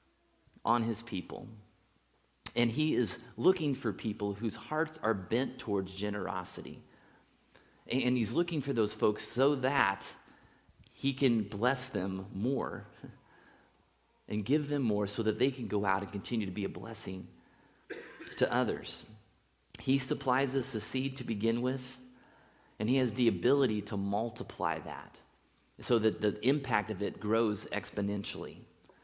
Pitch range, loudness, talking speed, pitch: 105-130 Hz, -33 LUFS, 145 wpm, 115 Hz